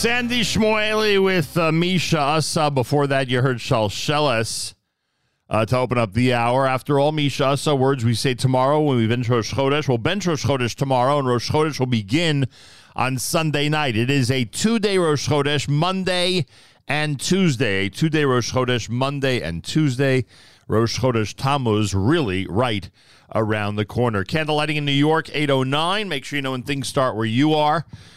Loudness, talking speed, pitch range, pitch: -20 LUFS, 180 wpm, 120-150 Hz, 135 Hz